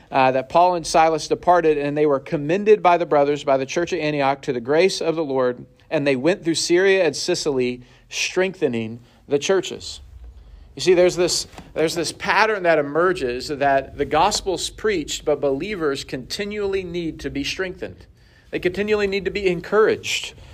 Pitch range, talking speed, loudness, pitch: 135-180 Hz, 175 wpm, -20 LUFS, 155 Hz